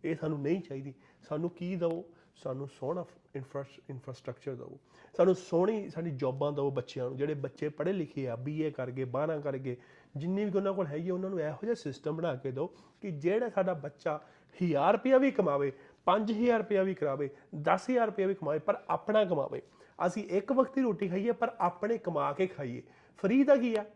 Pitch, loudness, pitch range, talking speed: 170 Hz, -32 LUFS, 140-195 Hz, 190 wpm